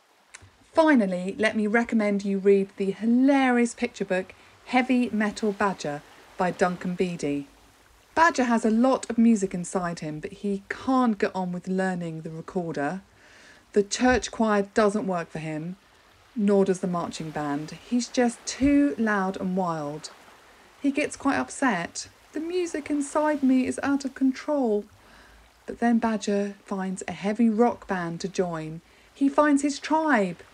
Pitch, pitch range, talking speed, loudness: 205 Hz, 185-245 Hz, 150 wpm, -25 LUFS